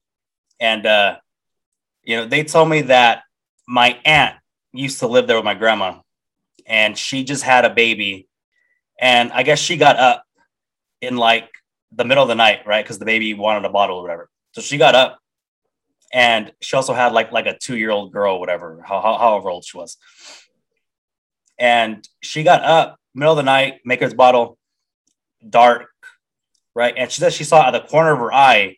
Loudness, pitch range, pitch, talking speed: -15 LUFS, 115-155 Hz, 125 Hz, 190 wpm